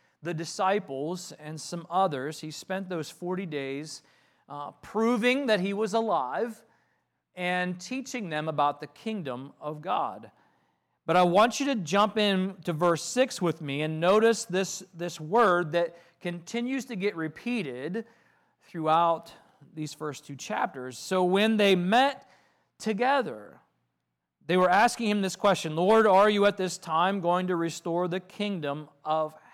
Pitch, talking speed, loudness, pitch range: 180 Hz, 150 wpm, -27 LUFS, 155-210 Hz